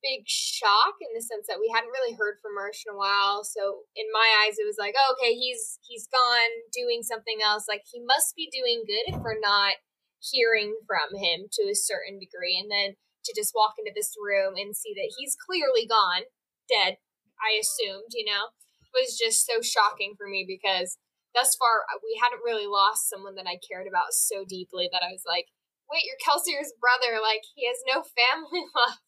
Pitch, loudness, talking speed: 230 Hz, -25 LUFS, 205 wpm